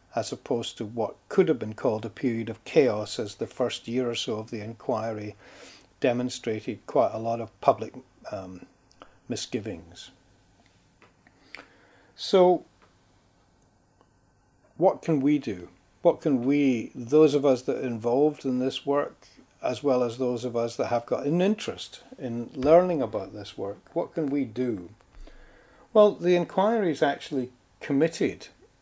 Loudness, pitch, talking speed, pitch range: -26 LUFS, 120 Hz, 150 wpm, 110-140 Hz